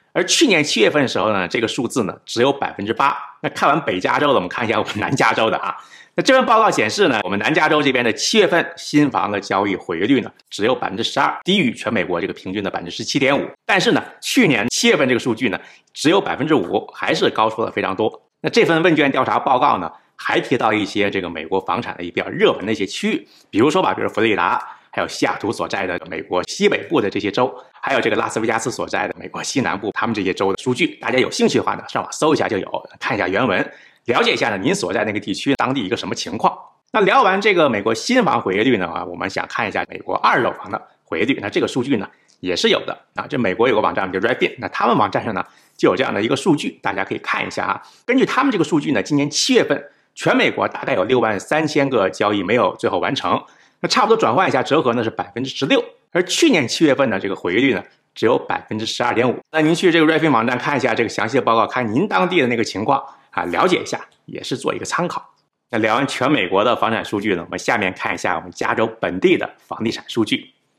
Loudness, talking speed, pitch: -18 LUFS, 395 characters per minute, 155 Hz